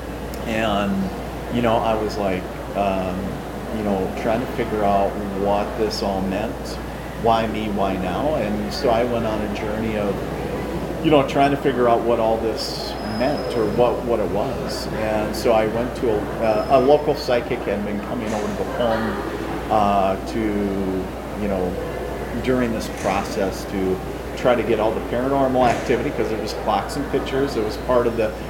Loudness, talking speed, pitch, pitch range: -22 LUFS, 180 wpm, 110 Hz, 100-120 Hz